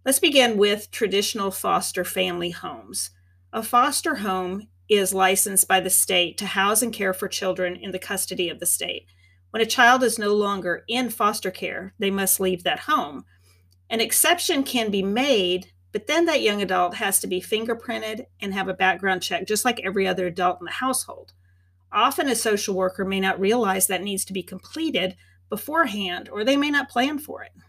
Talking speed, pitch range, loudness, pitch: 190 wpm, 185-230 Hz, -22 LUFS, 195 Hz